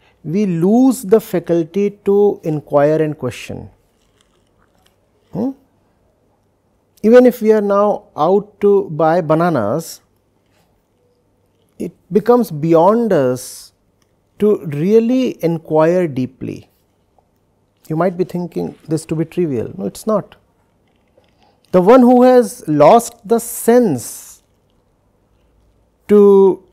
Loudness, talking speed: -14 LUFS, 100 wpm